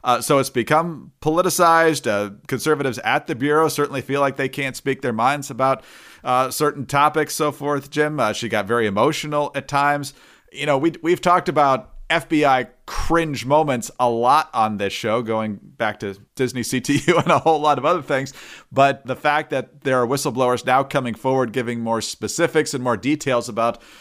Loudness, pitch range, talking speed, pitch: -20 LUFS, 125-150 Hz, 185 wpm, 140 Hz